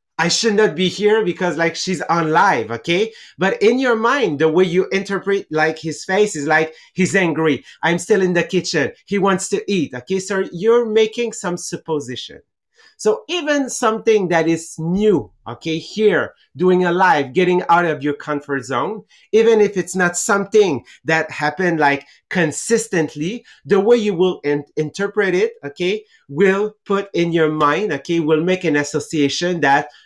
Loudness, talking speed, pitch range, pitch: -18 LUFS, 170 wpm, 155-205 Hz, 180 Hz